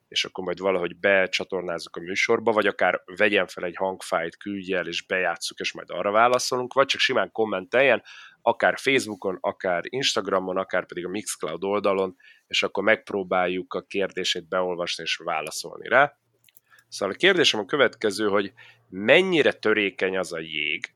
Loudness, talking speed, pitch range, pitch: -24 LUFS, 155 wpm, 95-105 Hz, 95 Hz